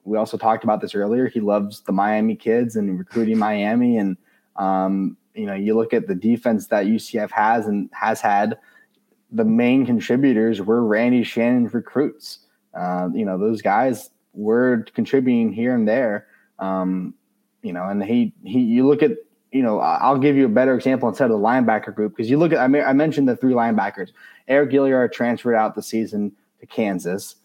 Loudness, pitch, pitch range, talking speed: -20 LUFS, 120 Hz, 105-140 Hz, 190 wpm